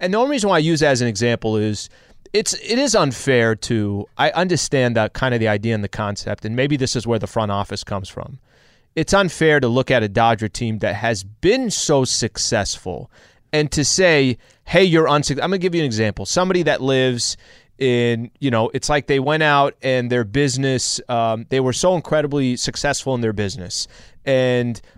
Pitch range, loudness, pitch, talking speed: 115-150 Hz, -18 LUFS, 130 Hz, 210 wpm